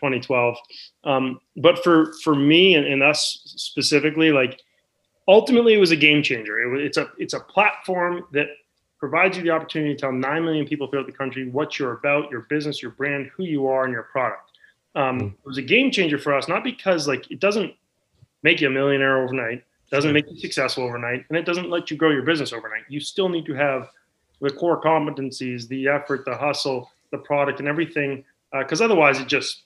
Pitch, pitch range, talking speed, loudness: 145 Hz, 135-160 Hz, 205 wpm, -21 LUFS